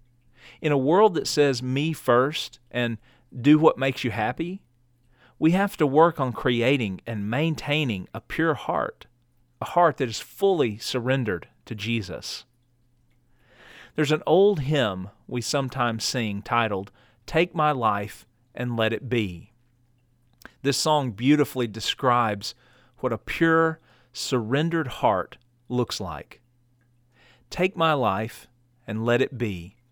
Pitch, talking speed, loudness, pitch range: 125 Hz, 130 wpm, -24 LUFS, 120-145 Hz